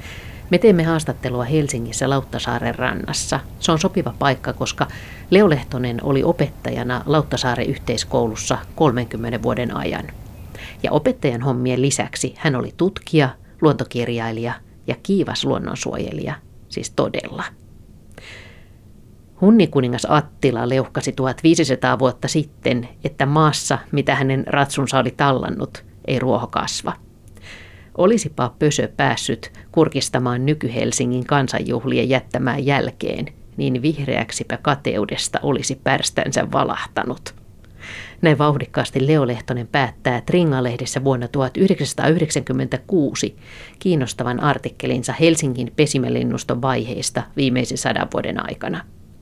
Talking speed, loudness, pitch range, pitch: 95 wpm, -20 LUFS, 120-145 Hz, 130 Hz